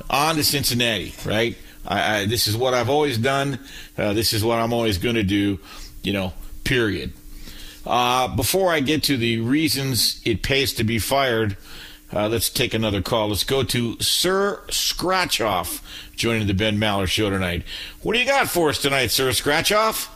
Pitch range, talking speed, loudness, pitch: 105-140 Hz, 180 wpm, -21 LUFS, 115 Hz